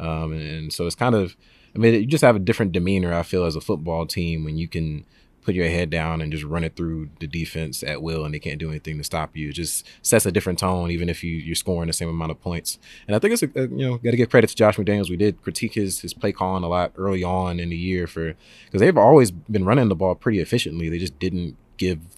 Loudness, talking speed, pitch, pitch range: -22 LUFS, 280 wpm, 85 Hz, 80-100 Hz